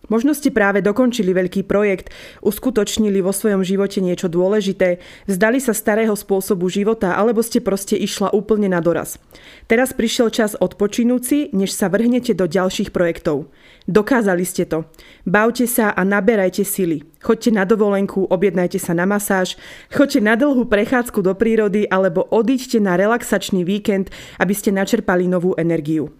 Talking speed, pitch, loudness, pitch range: 150 wpm, 205 Hz, -17 LUFS, 185-225 Hz